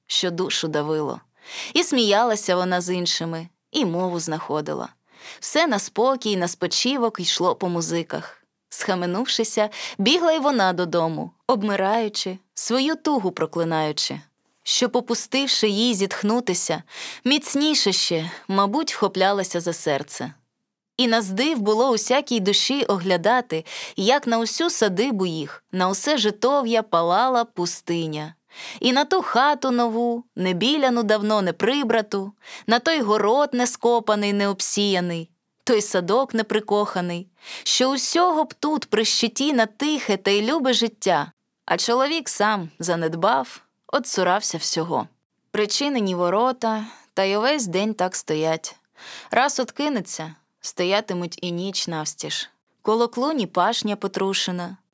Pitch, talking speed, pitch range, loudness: 210 Hz, 120 wpm, 180-245 Hz, -21 LUFS